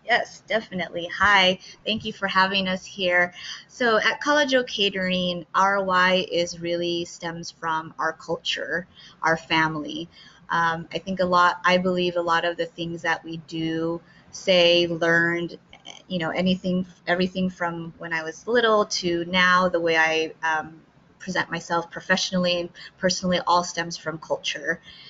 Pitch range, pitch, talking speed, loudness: 165-185 Hz, 175 Hz, 155 wpm, -23 LUFS